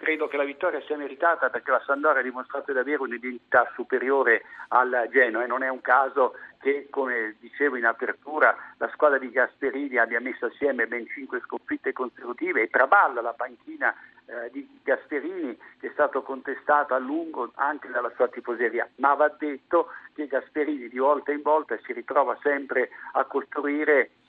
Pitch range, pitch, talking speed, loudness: 130-170 Hz, 145 Hz, 170 wpm, -25 LUFS